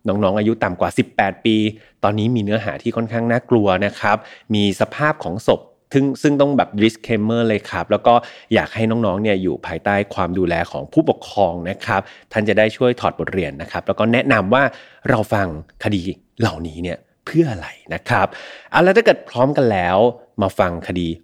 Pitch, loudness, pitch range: 110 Hz, -18 LUFS, 95-115 Hz